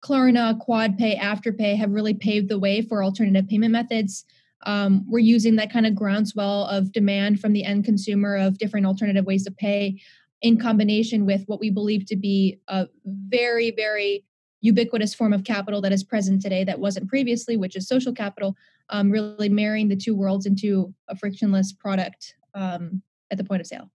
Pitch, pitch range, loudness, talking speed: 205 Hz, 195-220 Hz, -22 LUFS, 185 wpm